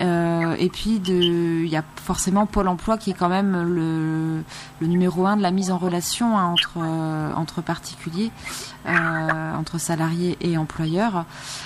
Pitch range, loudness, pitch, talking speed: 160-185 Hz, -23 LUFS, 170 Hz, 160 wpm